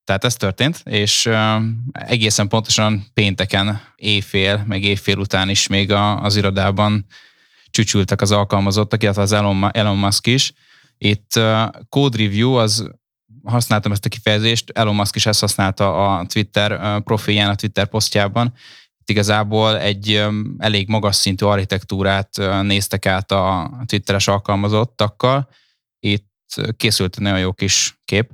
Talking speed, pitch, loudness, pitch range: 130 wpm, 105 Hz, -17 LUFS, 100-110 Hz